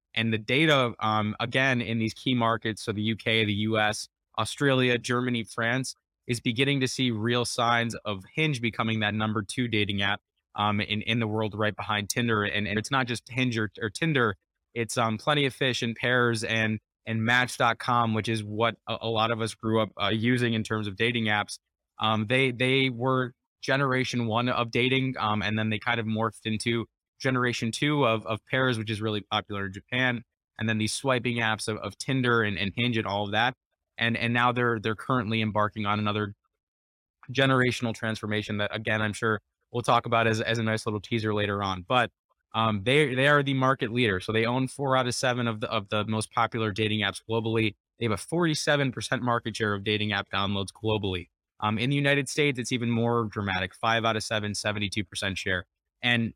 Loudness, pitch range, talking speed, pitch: -27 LUFS, 105-125 Hz, 210 wpm, 115 Hz